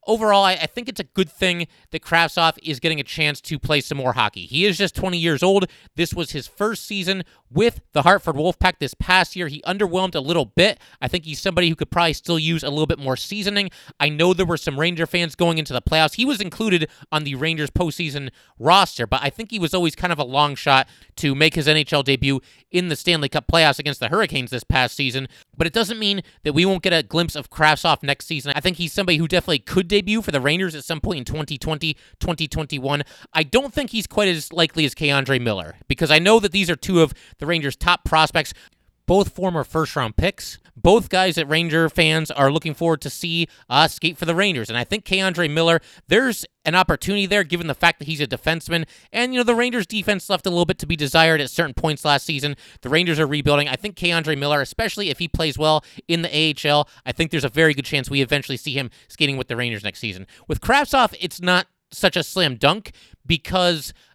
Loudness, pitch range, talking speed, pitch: -20 LUFS, 145-185 Hz, 235 wpm, 165 Hz